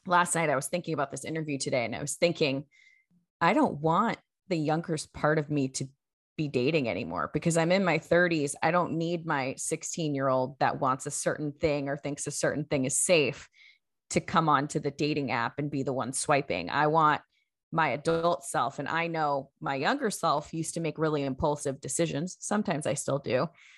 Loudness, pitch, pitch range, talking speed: -29 LUFS, 150 Hz, 140-165 Hz, 205 wpm